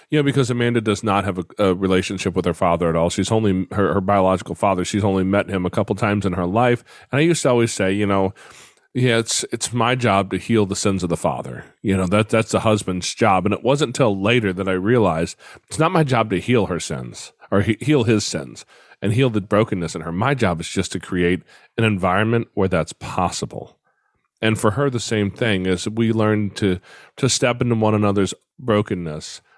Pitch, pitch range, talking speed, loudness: 105 Hz, 95-115 Hz, 230 wpm, -20 LUFS